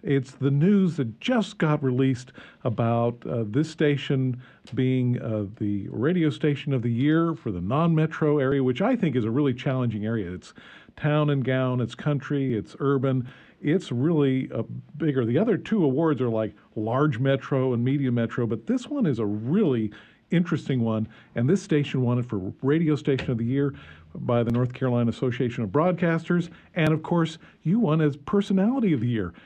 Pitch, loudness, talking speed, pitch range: 135 Hz, -25 LUFS, 185 wpm, 120-155 Hz